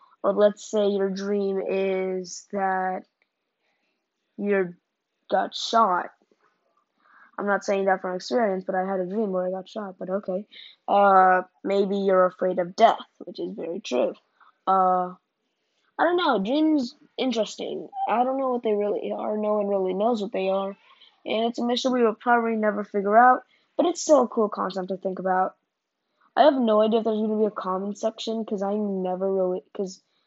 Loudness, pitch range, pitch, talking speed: -24 LUFS, 190-230 Hz, 205 Hz, 185 wpm